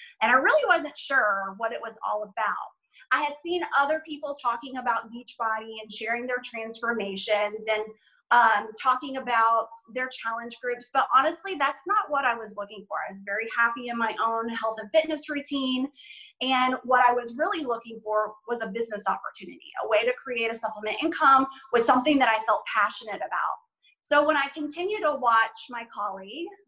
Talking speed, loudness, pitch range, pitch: 185 wpm, -26 LUFS, 225-290 Hz, 240 Hz